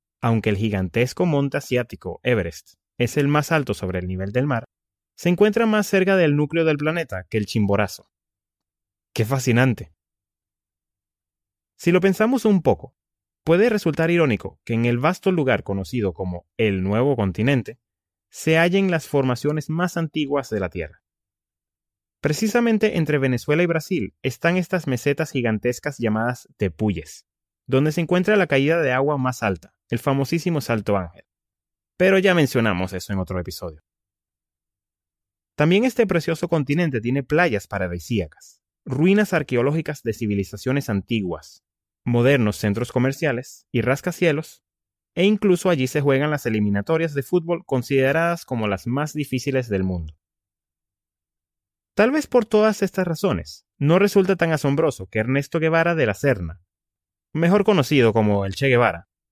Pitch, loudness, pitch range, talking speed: 125 Hz, -21 LUFS, 100-160 Hz, 145 wpm